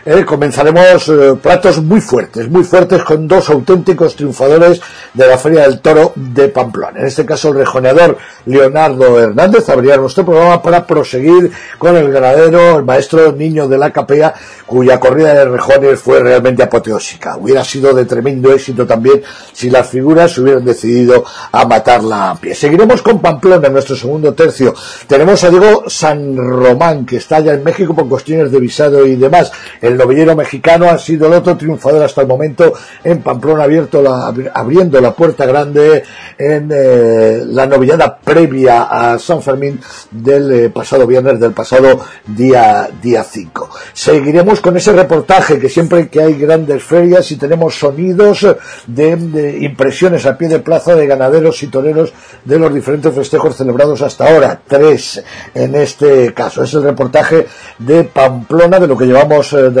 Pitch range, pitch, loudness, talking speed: 130-165 Hz, 150 Hz, -8 LUFS, 170 wpm